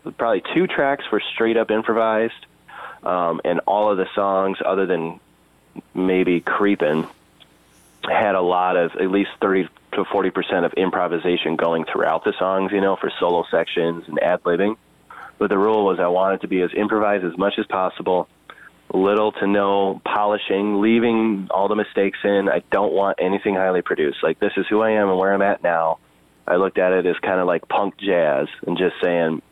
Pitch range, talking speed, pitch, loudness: 85-100 Hz, 190 wpm, 95 Hz, -20 LUFS